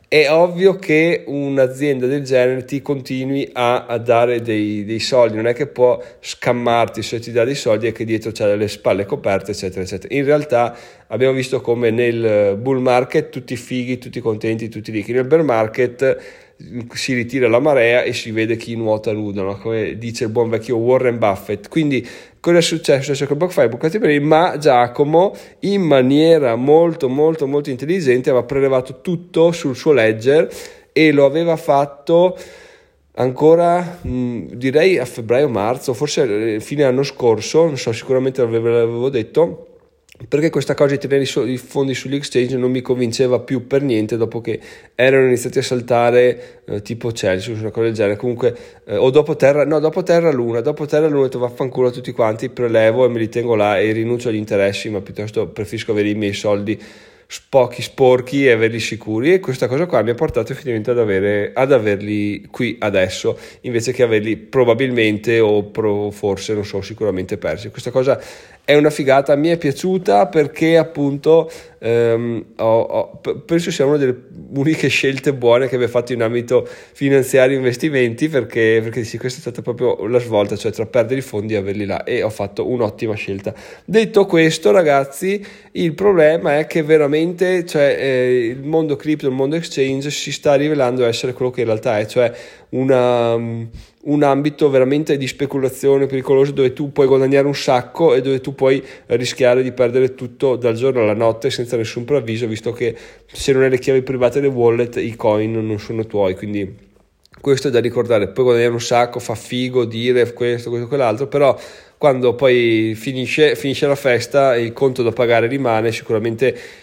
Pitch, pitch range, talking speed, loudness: 125 Hz, 115-145 Hz, 180 wpm, -17 LUFS